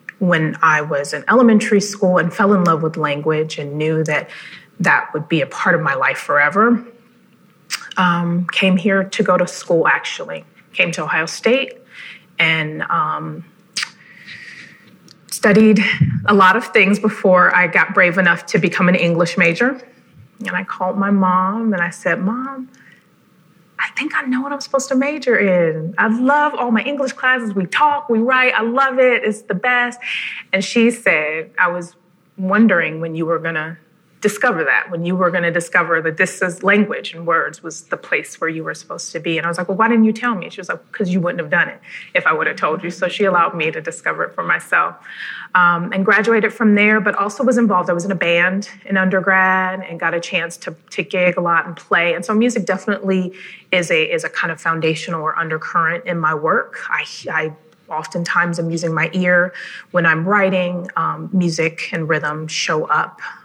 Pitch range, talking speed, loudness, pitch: 170-215 Hz, 200 wpm, -16 LUFS, 185 Hz